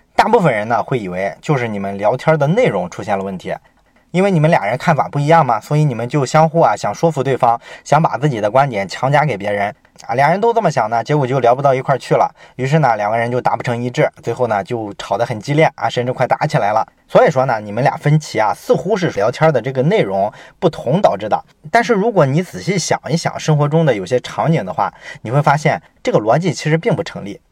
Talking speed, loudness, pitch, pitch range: 360 characters per minute, -16 LUFS, 140 Hz, 120-165 Hz